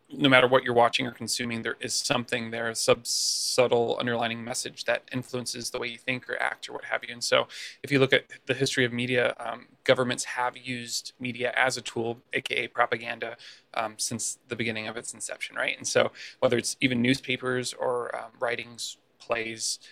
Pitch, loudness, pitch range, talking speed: 125 Hz, -27 LUFS, 115-130 Hz, 200 wpm